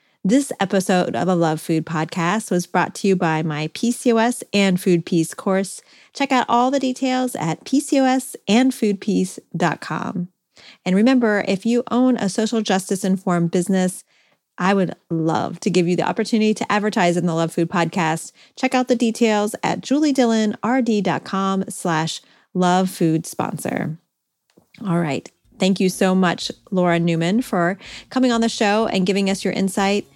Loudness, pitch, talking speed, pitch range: -20 LUFS, 195 Hz, 155 wpm, 175-230 Hz